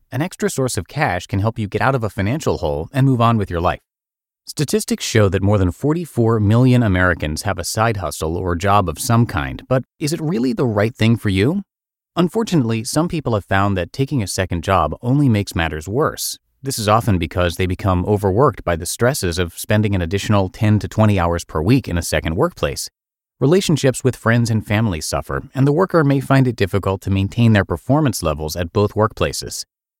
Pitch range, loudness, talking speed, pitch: 95-130 Hz, -18 LUFS, 210 wpm, 105 Hz